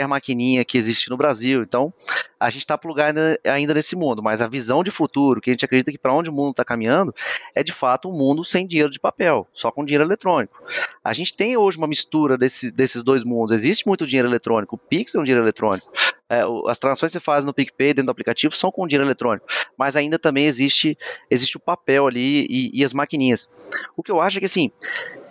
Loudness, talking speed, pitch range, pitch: -20 LUFS, 230 wpm, 125-160 Hz, 140 Hz